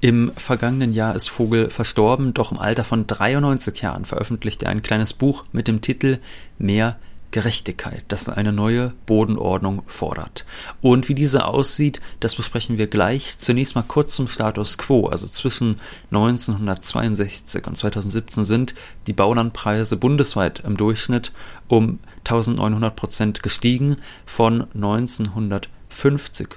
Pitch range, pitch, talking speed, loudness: 105-125 Hz, 115 Hz, 130 wpm, -20 LUFS